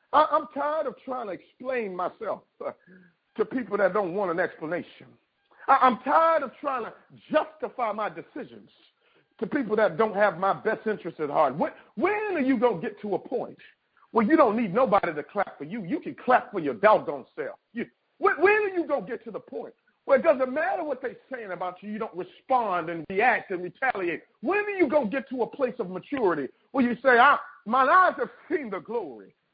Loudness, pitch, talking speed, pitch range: -26 LUFS, 255 Hz, 205 wpm, 210-300 Hz